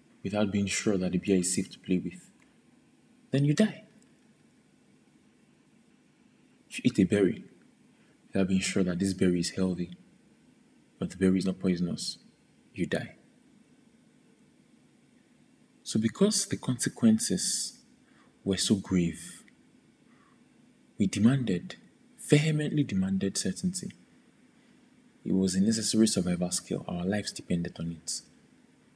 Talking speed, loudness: 120 wpm, -29 LUFS